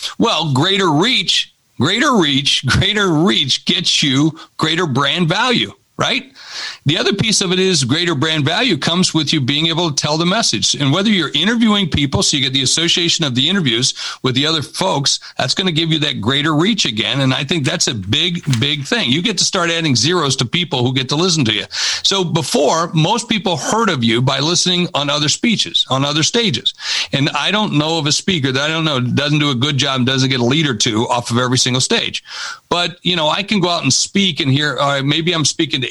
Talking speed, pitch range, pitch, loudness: 230 wpm, 135-175 Hz, 155 Hz, -14 LUFS